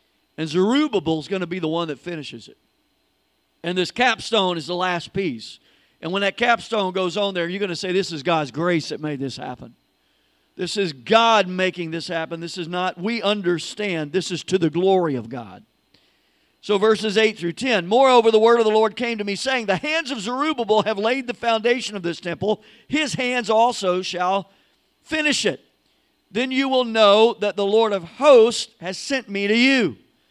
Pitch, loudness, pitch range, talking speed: 200 Hz, -20 LUFS, 175-230 Hz, 200 wpm